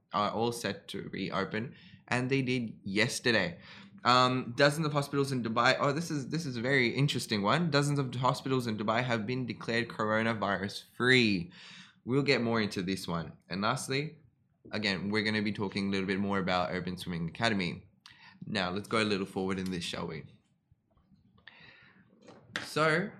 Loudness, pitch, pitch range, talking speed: -31 LUFS, 115 Hz, 100-135 Hz, 175 wpm